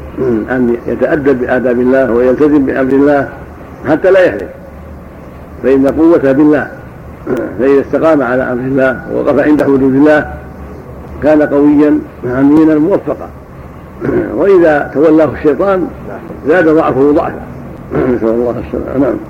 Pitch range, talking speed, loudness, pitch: 120-150 Hz, 110 wpm, -10 LUFS, 135 Hz